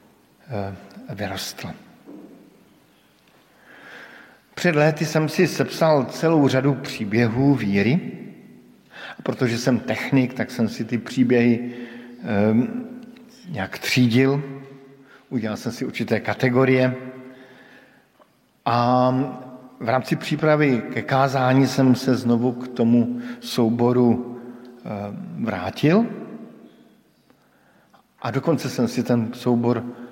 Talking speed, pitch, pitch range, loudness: 95 wpm, 130 Hz, 120-140 Hz, -21 LUFS